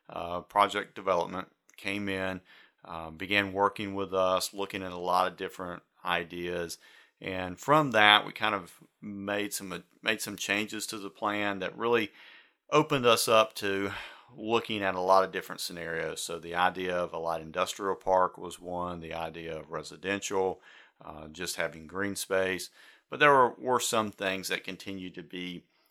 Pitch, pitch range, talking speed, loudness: 95 Hz, 90-100 Hz, 170 wpm, -29 LUFS